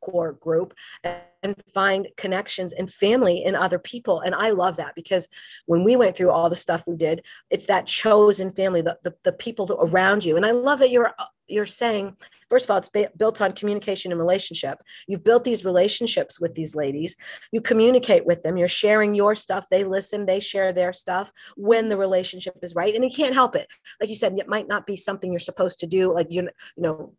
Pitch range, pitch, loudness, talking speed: 175-210 Hz, 190 Hz, -22 LUFS, 215 wpm